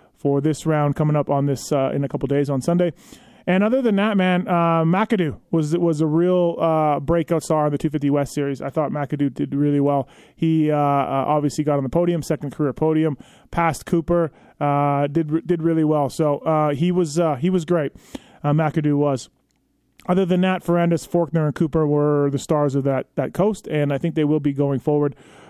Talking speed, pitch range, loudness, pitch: 210 wpm, 145-170 Hz, -20 LUFS, 155 Hz